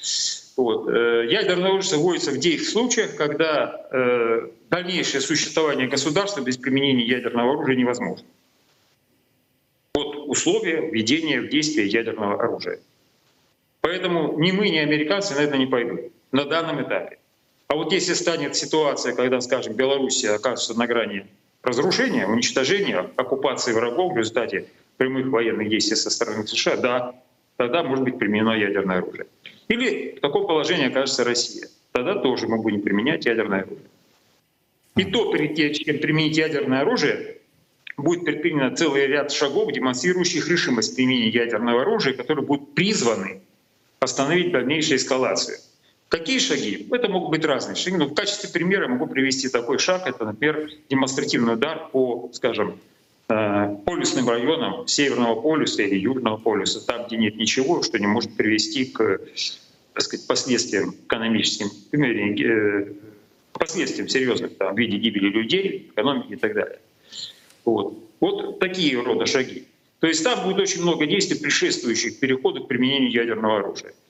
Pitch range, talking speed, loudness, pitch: 115-175 Hz, 140 wpm, -22 LUFS, 130 Hz